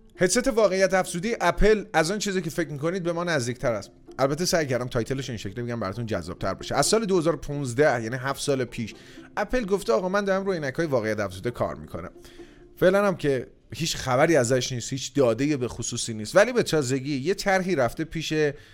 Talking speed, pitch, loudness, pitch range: 200 wpm, 145 Hz, -25 LUFS, 120-185 Hz